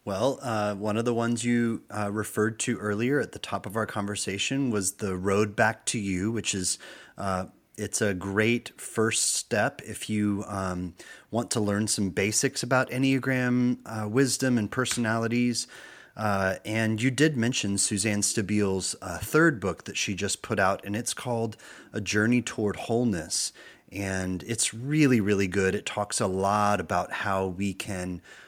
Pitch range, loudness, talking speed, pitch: 100-120 Hz, -27 LUFS, 170 wpm, 105 Hz